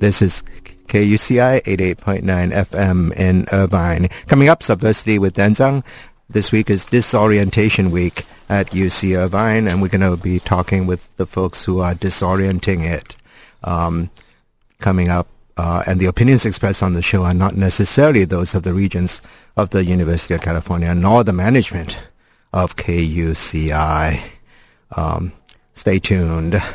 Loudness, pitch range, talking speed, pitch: -16 LUFS, 90-105 Hz, 145 wpm, 95 Hz